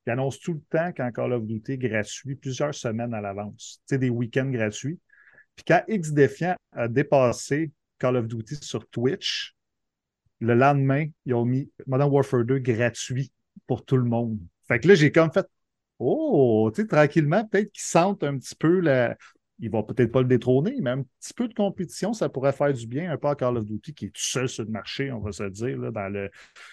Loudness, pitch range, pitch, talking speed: -25 LUFS, 120-150 Hz, 130 Hz, 210 wpm